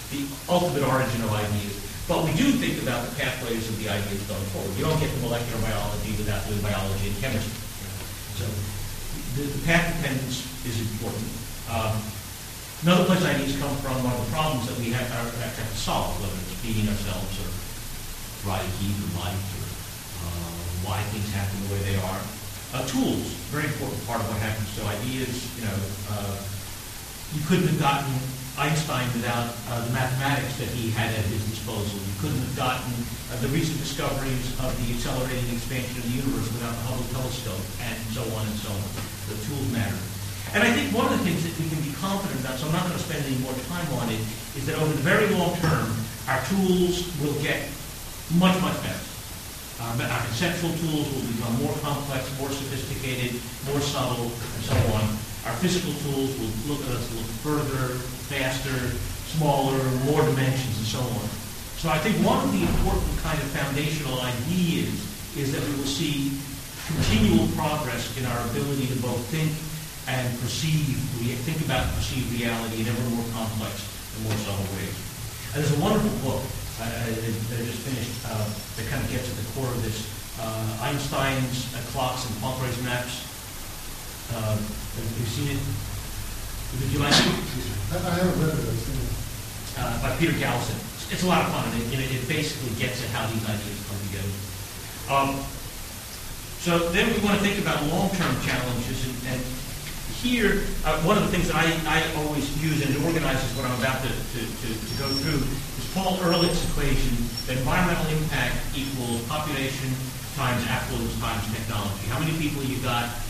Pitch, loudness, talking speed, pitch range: 125 Hz, -27 LUFS, 180 wpm, 110-140 Hz